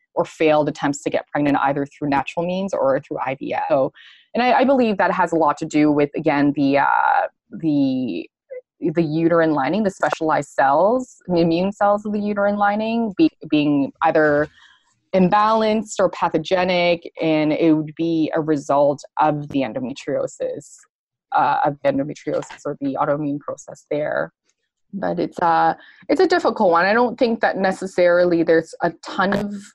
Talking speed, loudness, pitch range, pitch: 165 wpm, -19 LUFS, 155-230 Hz, 175 Hz